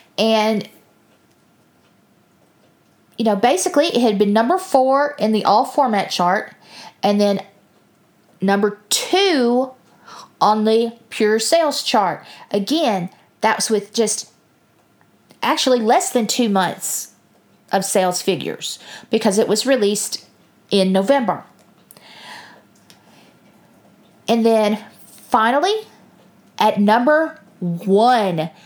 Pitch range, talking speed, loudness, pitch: 205-260 Hz, 100 wpm, -18 LUFS, 220 Hz